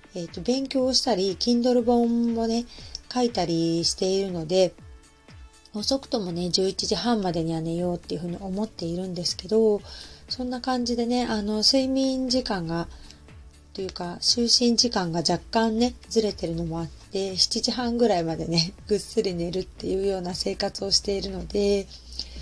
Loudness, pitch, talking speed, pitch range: -25 LUFS, 195 Hz, 330 characters per minute, 175-235 Hz